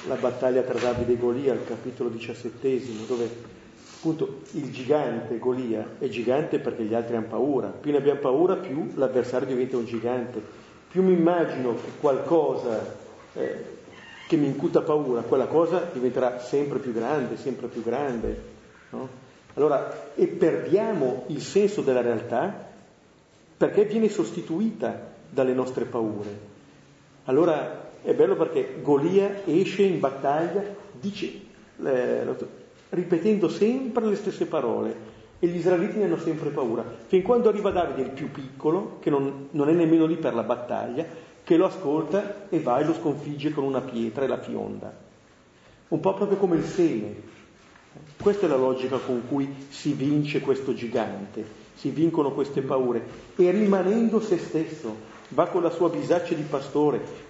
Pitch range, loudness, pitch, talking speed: 120-180 Hz, -25 LUFS, 145 Hz, 155 wpm